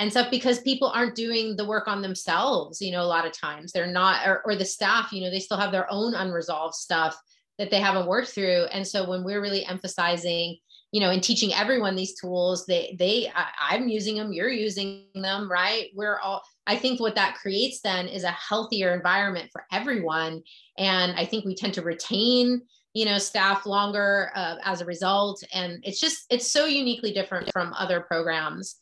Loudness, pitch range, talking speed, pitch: -25 LUFS, 180-215 Hz, 200 wpm, 195 Hz